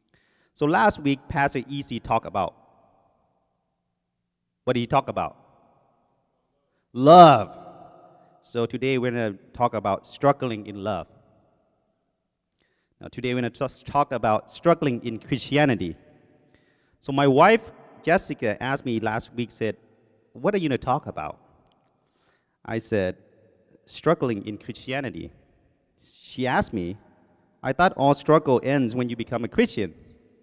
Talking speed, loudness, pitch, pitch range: 130 wpm, -23 LUFS, 120 Hz, 110-140 Hz